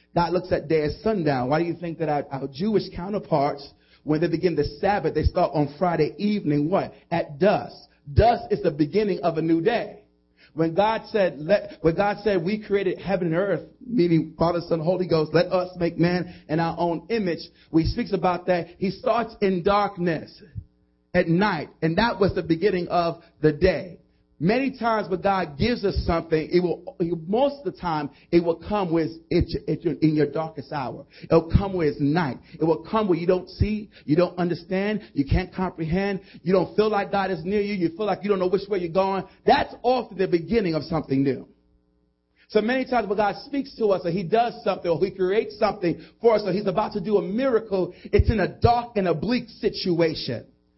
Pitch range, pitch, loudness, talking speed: 160-205 Hz, 180 Hz, -24 LUFS, 210 wpm